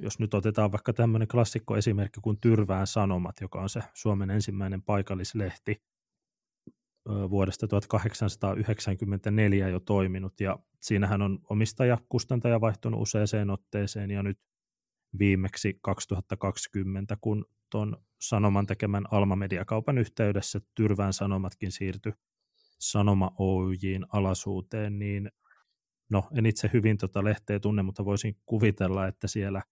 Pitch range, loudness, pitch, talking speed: 95-110 Hz, -29 LUFS, 100 Hz, 115 wpm